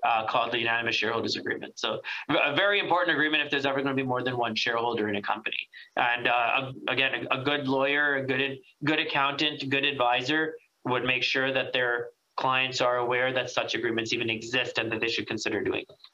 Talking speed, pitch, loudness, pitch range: 205 wpm, 130 Hz, -26 LUFS, 125-145 Hz